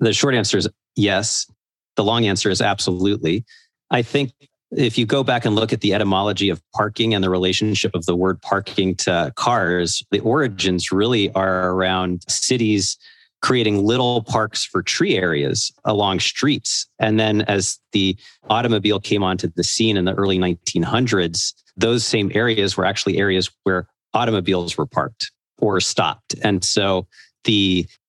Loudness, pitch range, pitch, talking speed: -19 LUFS, 95-115 Hz, 100 Hz, 160 wpm